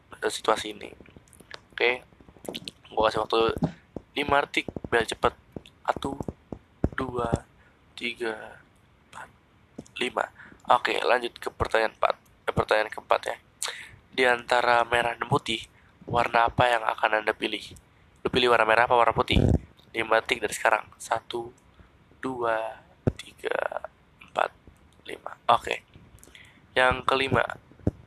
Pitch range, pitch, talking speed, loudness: 110-125 Hz, 115 Hz, 120 wpm, -26 LUFS